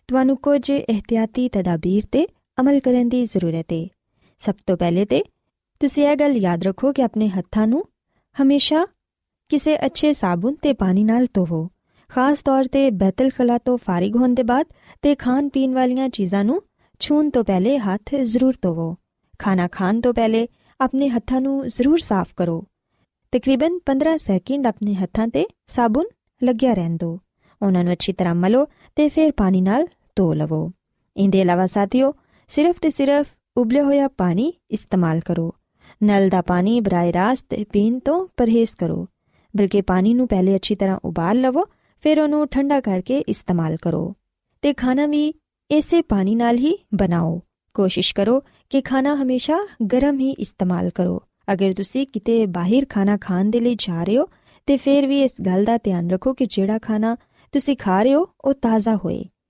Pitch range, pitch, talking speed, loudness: 195-275 Hz, 235 Hz, 160 wpm, -20 LUFS